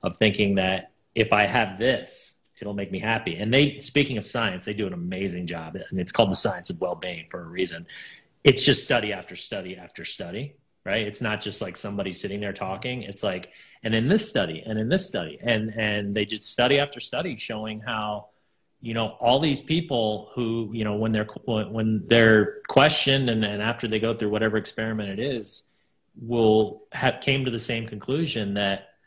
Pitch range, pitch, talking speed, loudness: 105-120 Hz, 110 Hz, 205 wpm, -25 LUFS